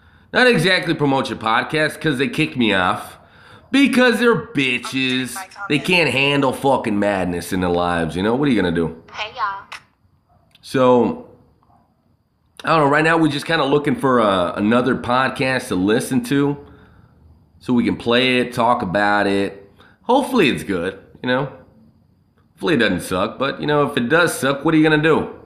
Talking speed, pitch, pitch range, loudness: 185 wpm, 130 Hz, 105-155 Hz, -18 LUFS